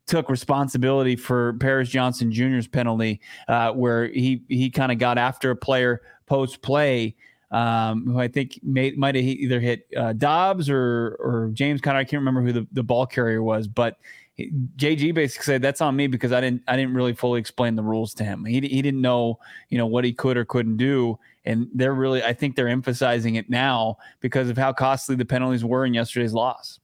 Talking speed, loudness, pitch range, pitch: 210 wpm, -23 LUFS, 120-135 Hz, 125 Hz